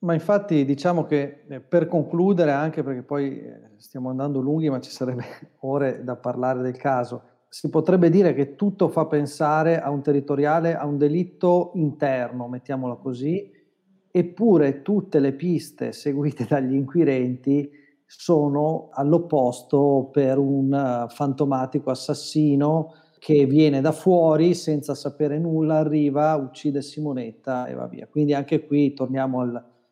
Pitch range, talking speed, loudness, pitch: 135-160 Hz, 135 wpm, -22 LUFS, 145 Hz